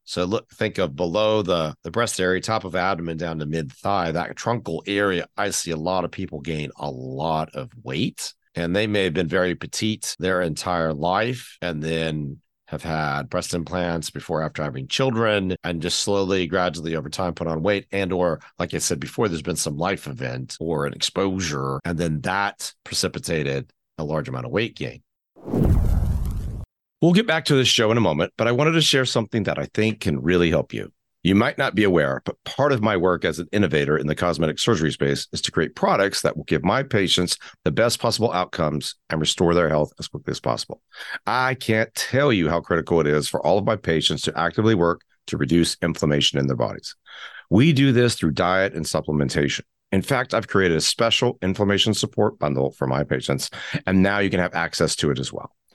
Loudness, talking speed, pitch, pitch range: -22 LUFS, 210 wpm, 90 Hz, 80-105 Hz